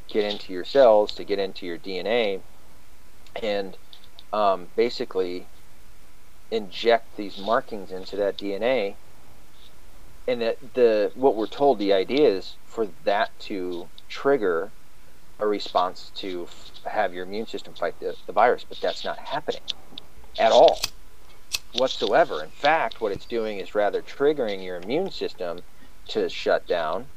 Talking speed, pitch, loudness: 140 wpm, 105 Hz, -25 LUFS